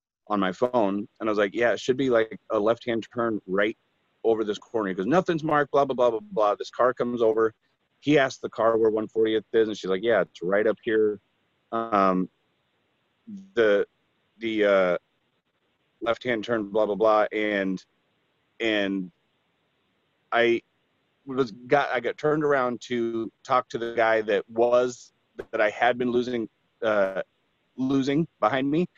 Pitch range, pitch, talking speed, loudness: 105-125 Hz, 115 Hz, 170 wpm, -25 LUFS